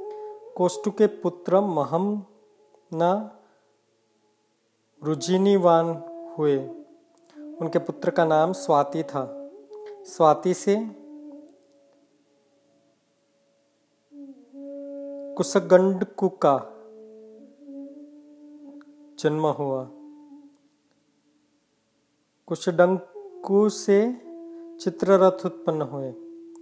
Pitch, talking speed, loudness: 210 Hz, 45 wpm, -23 LUFS